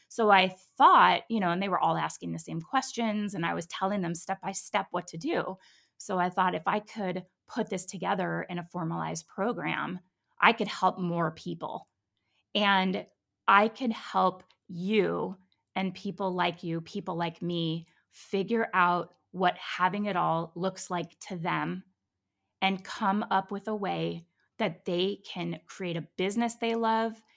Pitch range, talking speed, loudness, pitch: 175-200 Hz, 170 wpm, -29 LUFS, 185 Hz